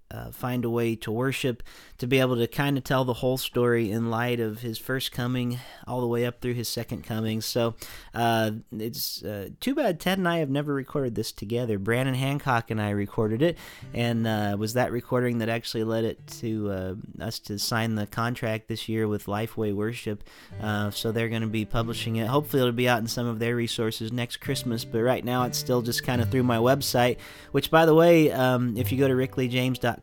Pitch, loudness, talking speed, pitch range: 120 Hz, -26 LUFS, 220 wpm, 110-130 Hz